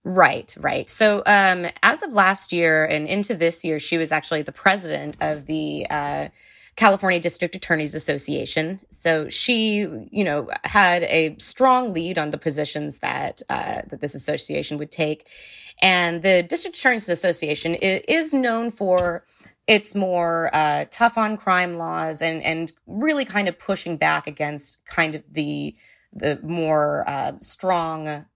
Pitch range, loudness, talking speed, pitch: 155-195 Hz, -21 LUFS, 150 wpm, 170 Hz